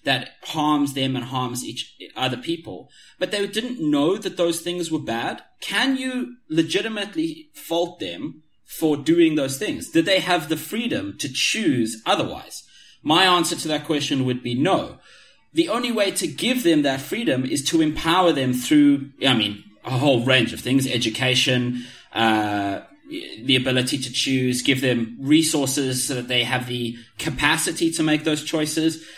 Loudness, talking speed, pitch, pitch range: -21 LUFS, 165 wpm, 150 Hz, 130-175 Hz